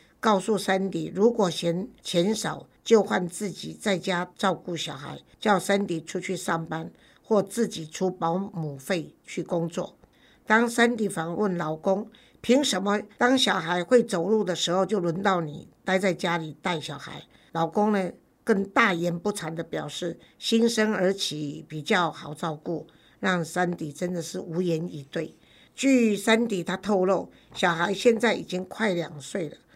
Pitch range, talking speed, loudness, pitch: 165-210 Hz, 225 characters per minute, -26 LUFS, 185 Hz